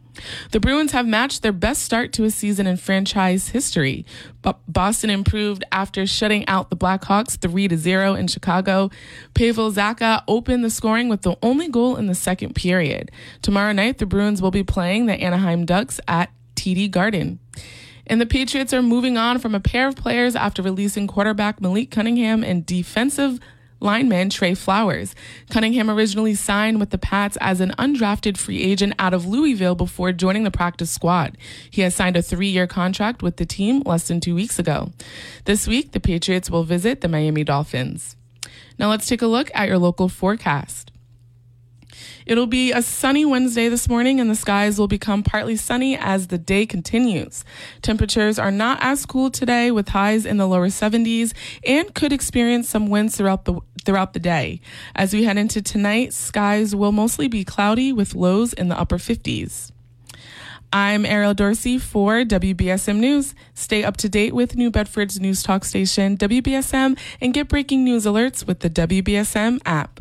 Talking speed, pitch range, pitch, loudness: 175 wpm, 180-230 Hz, 205 Hz, -19 LUFS